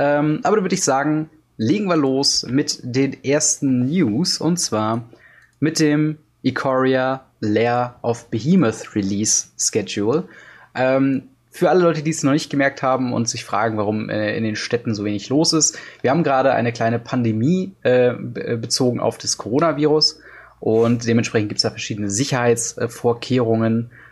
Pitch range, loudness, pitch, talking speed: 115-150 Hz, -19 LUFS, 130 Hz, 160 wpm